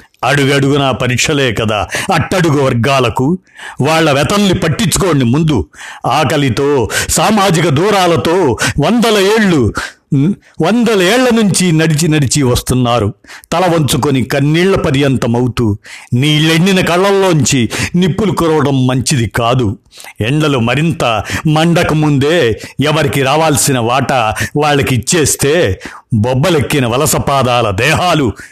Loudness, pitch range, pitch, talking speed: -11 LUFS, 125-165 Hz, 145 Hz, 90 wpm